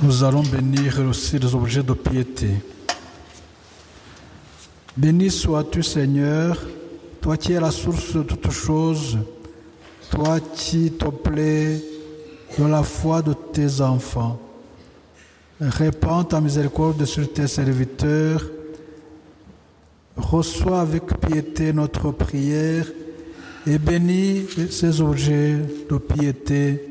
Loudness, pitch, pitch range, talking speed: -21 LUFS, 150 Hz, 130-155 Hz, 105 wpm